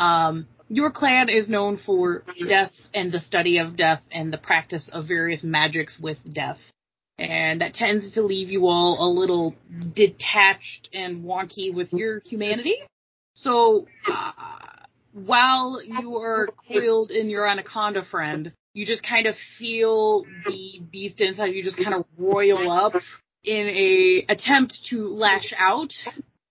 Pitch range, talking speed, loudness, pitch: 175-225 Hz, 145 wpm, -22 LUFS, 200 Hz